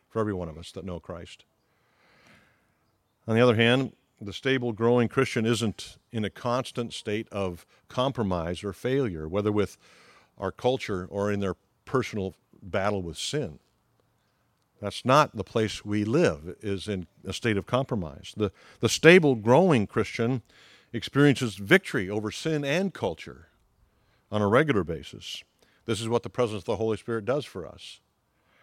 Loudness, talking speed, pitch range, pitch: -26 LUFS, 155 wpm, 100-120 Hz, 110 Hz